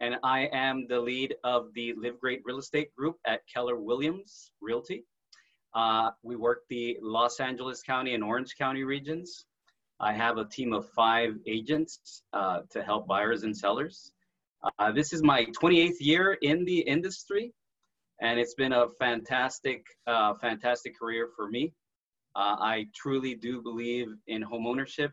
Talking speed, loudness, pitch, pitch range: 160 wpm, -30 LUFS, 120 Hz, 115-140 Hz